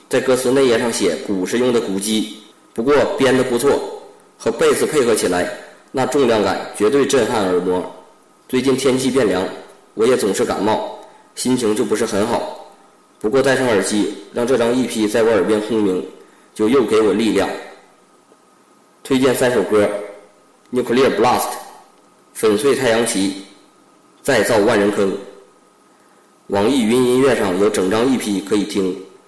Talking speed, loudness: 245 characters per minute, -17 LUFS